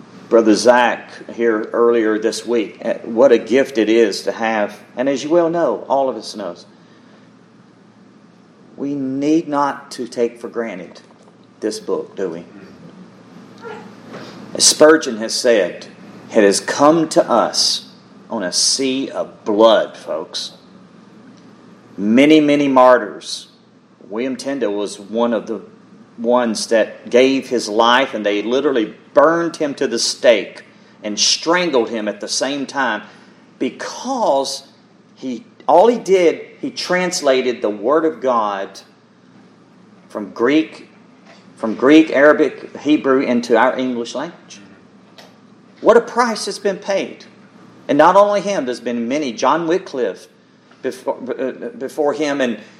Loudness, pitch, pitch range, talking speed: -16 LUFS, 130 Hz, 115-155 Hz, 135 wpm